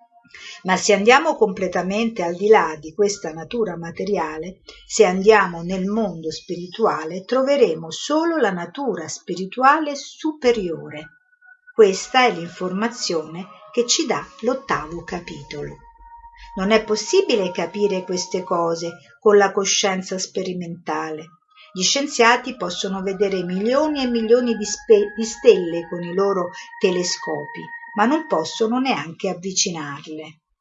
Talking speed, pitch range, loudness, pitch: 120 wpm, 175-240 Hz, -20 LUFS, 200 Hz